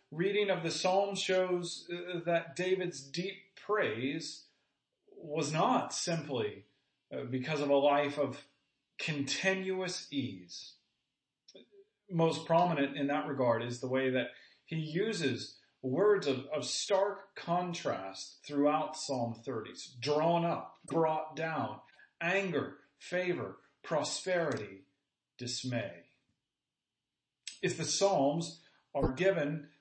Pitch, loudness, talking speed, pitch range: 155 Hz, -34 LUFS, 105 wpm, 135-180 Hz